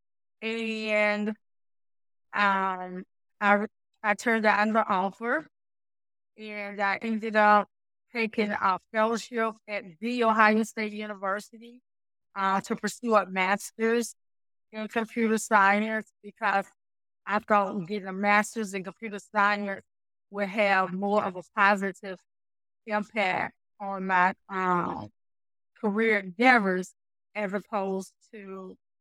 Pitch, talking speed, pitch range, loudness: 205 Hz, 110 wpm, 190-220 Hz, -27 LUFS